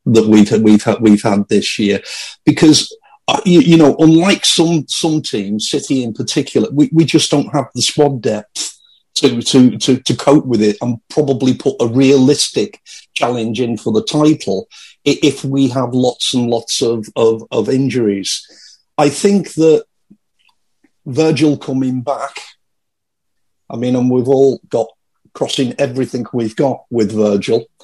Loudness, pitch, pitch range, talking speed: -13 LUFS, 130 Hz, 115-150 Hz, 155 wpm